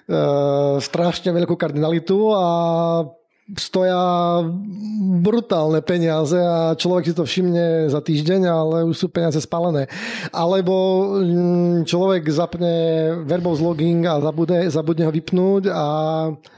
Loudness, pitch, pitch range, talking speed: -19 LUFS, 170 Hz, 160-180 Hz, 110 wpm